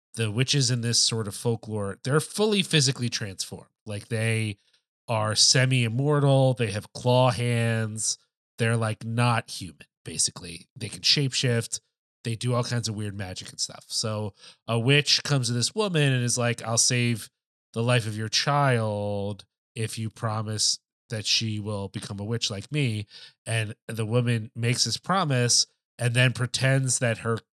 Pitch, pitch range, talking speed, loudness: 115 Hz, 110-130 Hz, 165 wpm, -25 LUFS